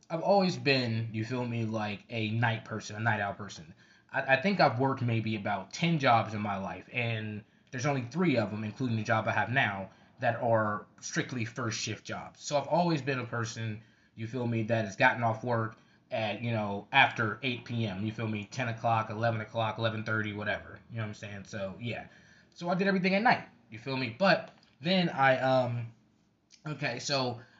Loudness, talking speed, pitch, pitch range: -31 LUFS, 210 wpm, 115 Hz, 110-130 Hz